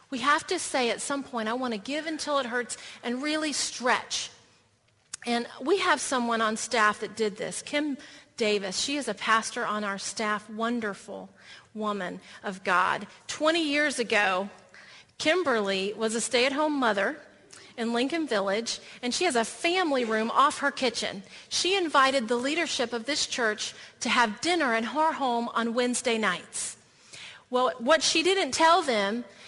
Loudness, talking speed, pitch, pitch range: -27 LUFS, 165 wpm, 240 Hz, 215-290 Hz